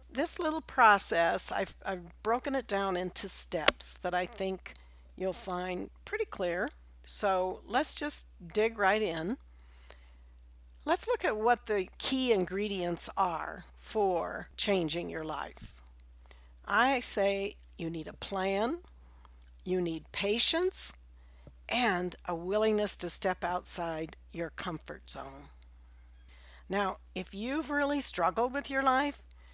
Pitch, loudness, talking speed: 180 Hz, -26 LUFS, 125 wpm